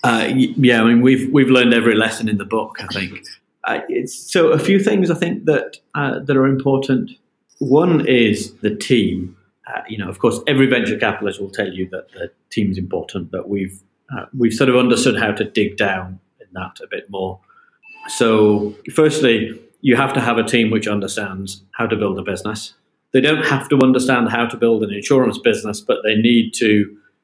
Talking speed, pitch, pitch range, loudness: 205 wpm, 115 Hz, 105-135 Hz, -17 LUFS